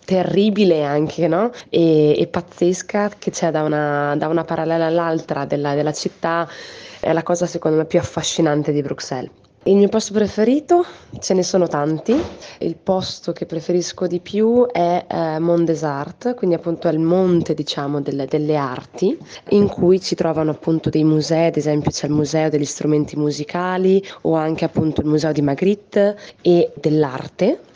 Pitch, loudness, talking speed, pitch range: 165 Hz, -19 LUFS, 170 wpm, 150-185 Hz